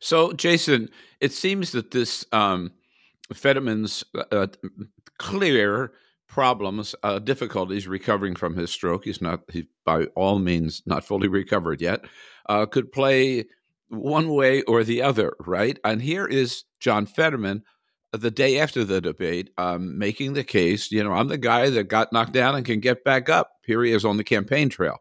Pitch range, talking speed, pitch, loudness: 100-135 Hz, 170 wpm, 115 Hz, -23 LUFS